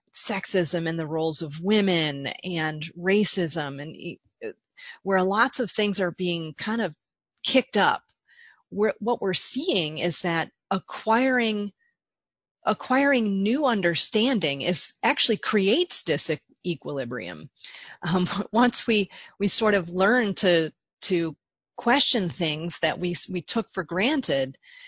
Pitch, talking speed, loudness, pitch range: 195 Hz, 125 wpm, -24 LUFS, 170-235 Hz